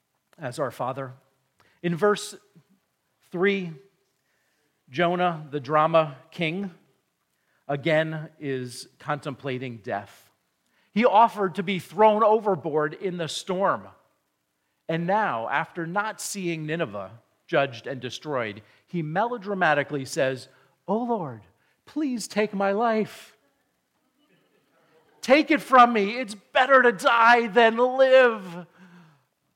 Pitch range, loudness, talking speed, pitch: 145-210 Hz, -24 LUFS, 105 wpm, 175 Hz